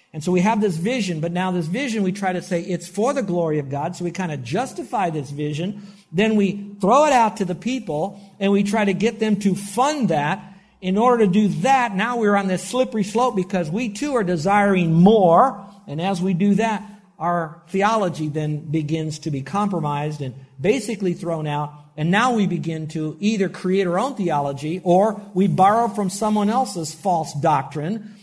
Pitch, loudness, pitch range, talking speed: 190 Hz, -21 LUFS, 170-210 Hz, 200 wpm